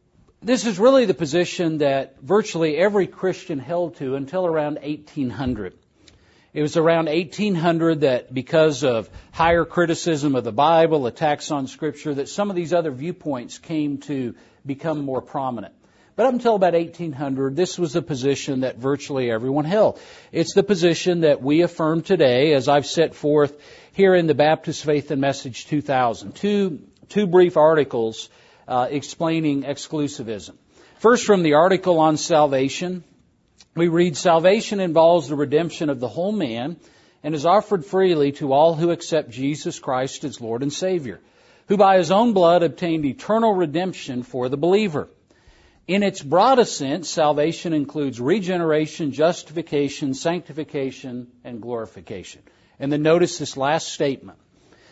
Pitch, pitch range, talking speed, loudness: 155 Hz, 140-175 Hz, 150 wpm, -20 LUFS